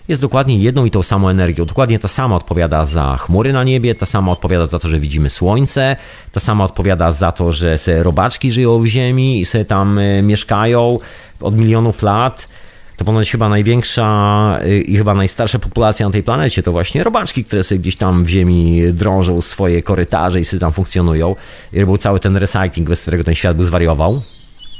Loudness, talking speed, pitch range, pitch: -14 LUFS, 190 wpm, 90-115 Hz, 100 Hz